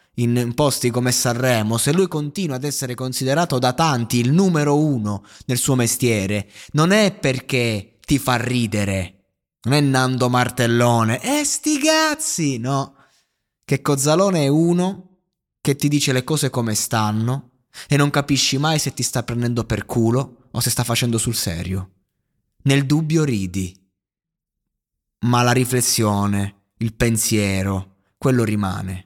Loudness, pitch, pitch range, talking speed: -19 LUFS, 125 Hz, 110-145 Hz, 145 wpm